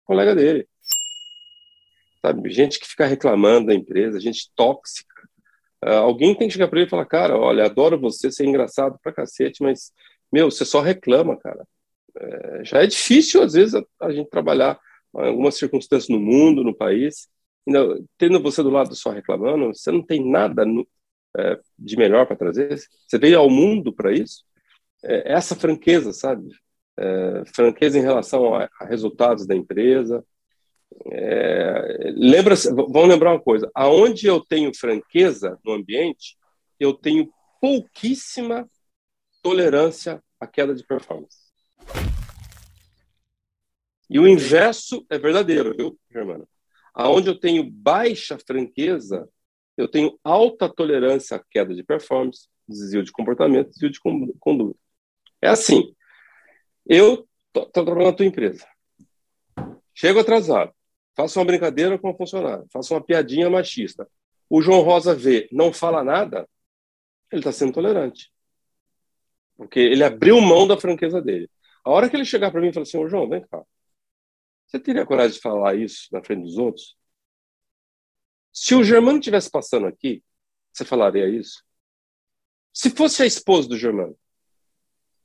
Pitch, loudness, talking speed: 175 Hz, -18 LUFS, 150 wpm